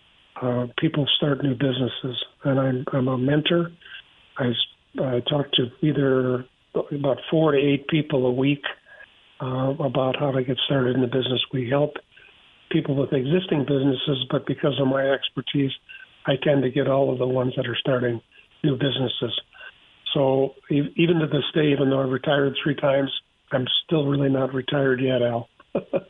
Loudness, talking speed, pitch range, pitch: -23 LUFS, 170 wpm, 130-145 Hz, 135 Hz